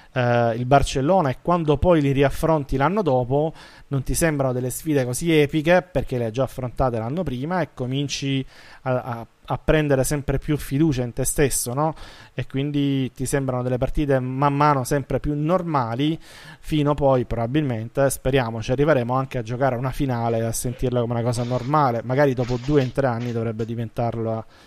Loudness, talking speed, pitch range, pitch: -22 LUFS, 180 wpm, 125-145 Hz, 135 Hz